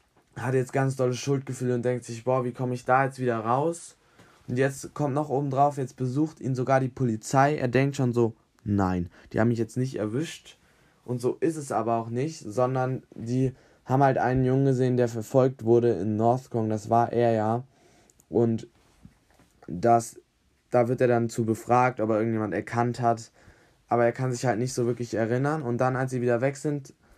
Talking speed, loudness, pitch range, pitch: 200 wpm, -26 LUFS, 115-130 Hz, 125 Hz